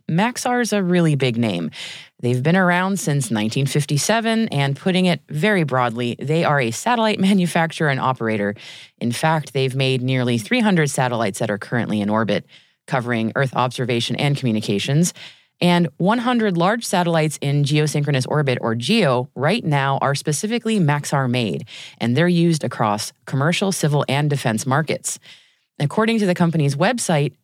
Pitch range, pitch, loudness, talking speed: 125-180 Hz, 145 Hz, -19 LUFS, 150 wpm